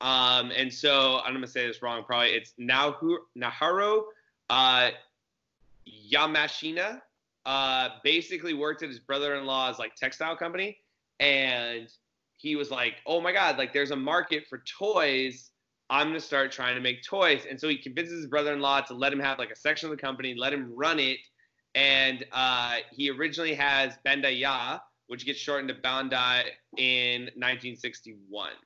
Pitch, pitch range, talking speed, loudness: 135 Hz, 125-150 Hz, 160 wpm, -27 LUFS